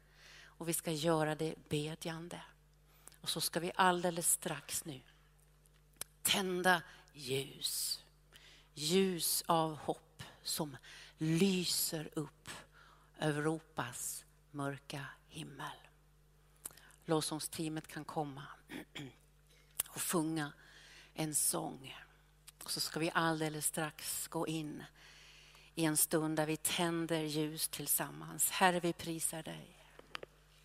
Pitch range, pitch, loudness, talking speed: 150-165 Hz, 155 Hz, -36 LUFS, 100 wpm